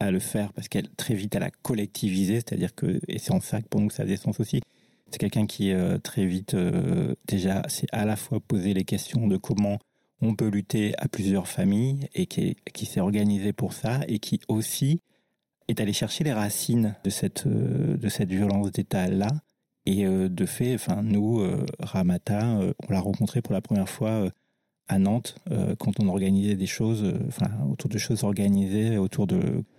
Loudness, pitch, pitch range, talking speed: -27 LUFS, 105 Hz, 100-115 Hz, 190 wpm